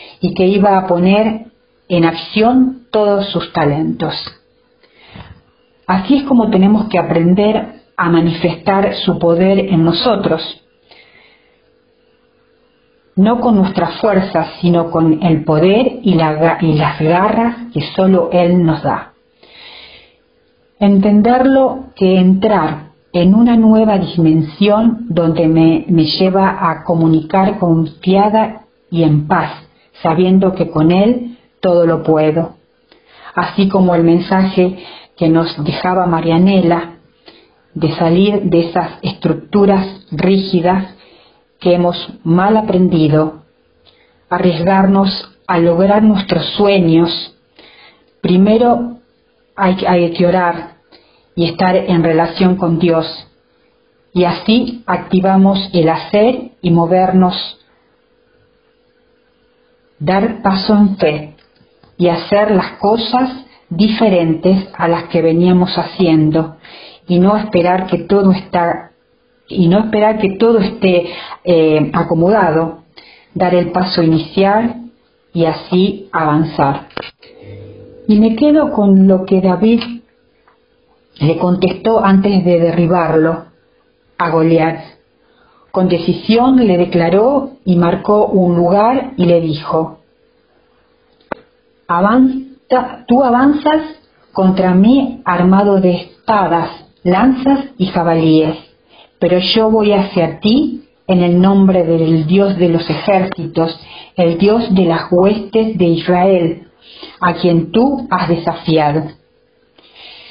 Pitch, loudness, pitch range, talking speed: 185 Hz, -12 LUFS, 170-210 Hz, 110 wpm